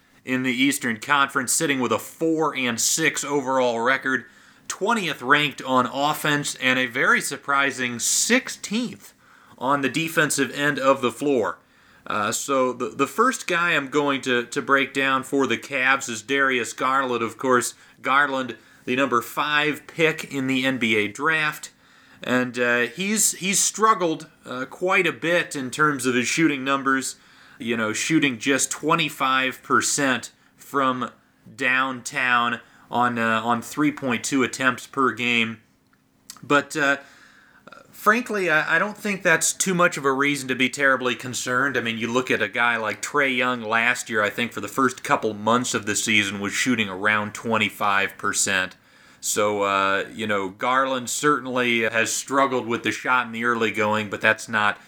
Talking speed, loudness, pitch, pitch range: 160 wpm, -22 LUFS, 130 Hz, 115-145 Hz